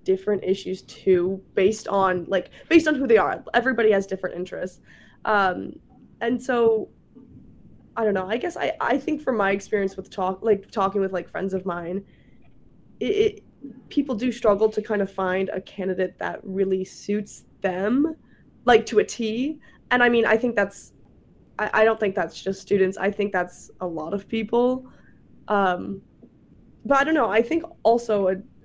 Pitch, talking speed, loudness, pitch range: 205 Hz, 180 wpm, -23 LUFS, 190-235 Hz